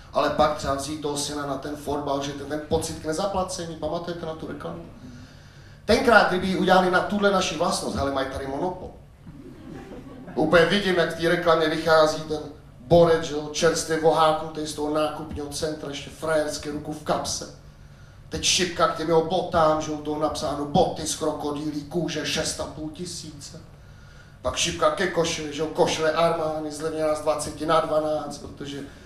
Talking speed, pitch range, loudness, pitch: 170 wpm, 145-165 Hz, -24 LUFS, 155 Hz